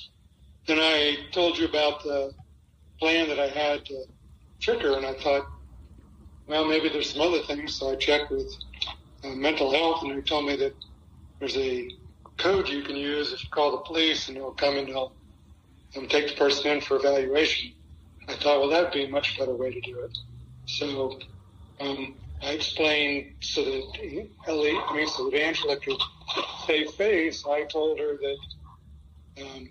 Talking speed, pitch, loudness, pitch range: 180 wpm, 140 Hz, -26 LUFS, 90-150 Hz